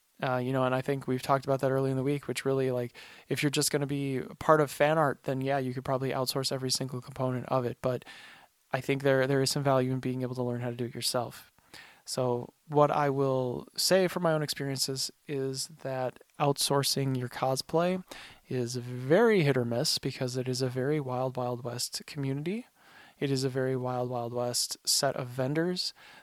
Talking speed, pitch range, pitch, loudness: 215 wpm, 125-145 Hz, 135 Hz, -30 LUFS